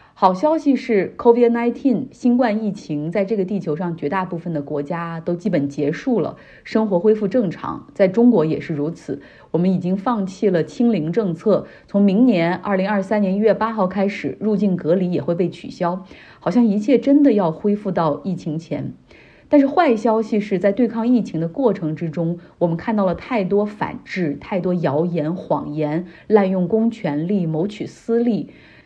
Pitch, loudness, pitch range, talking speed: 195 Hz, -19 LUFS, 170-230 Hz, 275 characters per minute